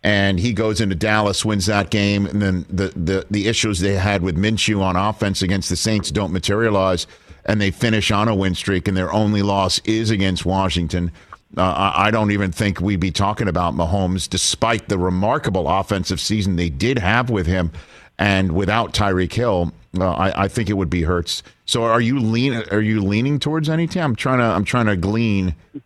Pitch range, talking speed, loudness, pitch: 95-110 Hz, 205 wpm, -19 LUFS, 100 Hz